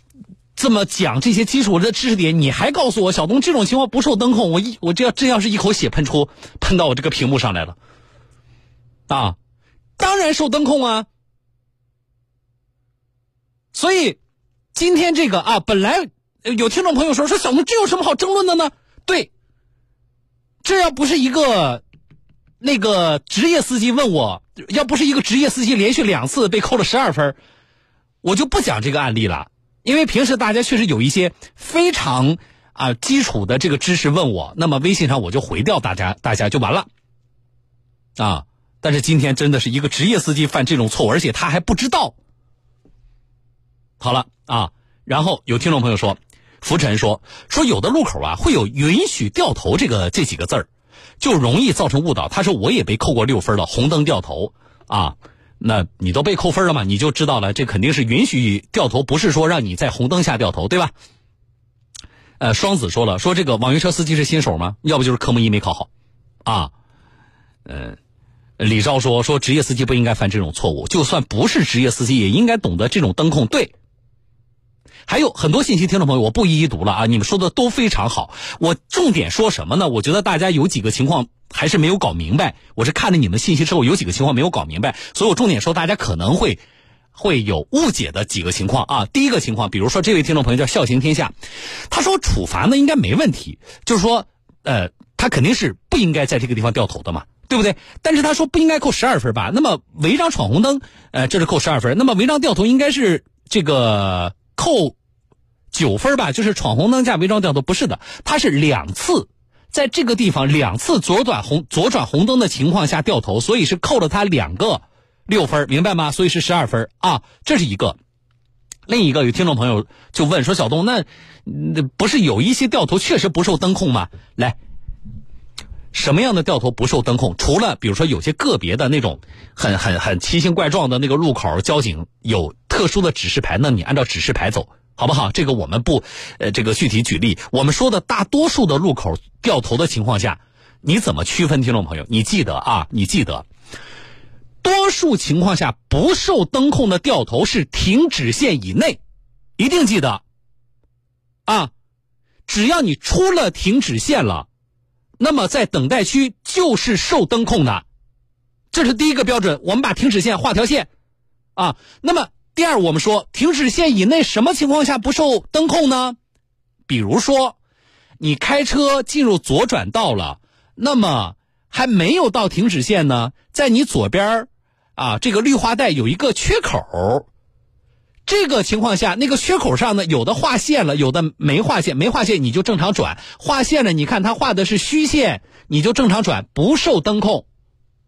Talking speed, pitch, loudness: 280 characters per minute, 150 Hz, -17 LUFS